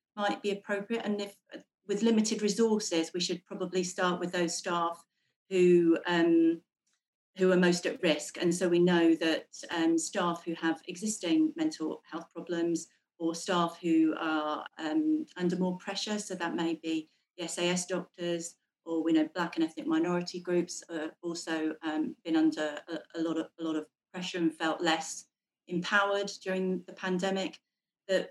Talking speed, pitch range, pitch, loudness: 170 wpm, 165-190 Hz, 175 Hz, -31 LUFS